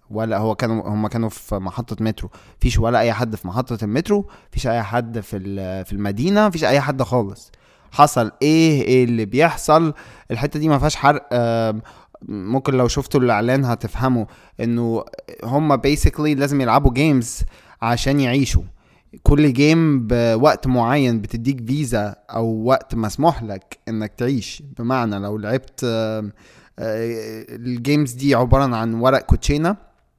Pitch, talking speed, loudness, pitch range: 120 Hz, 140 wpm, -19 LUFS, 110-140 Hz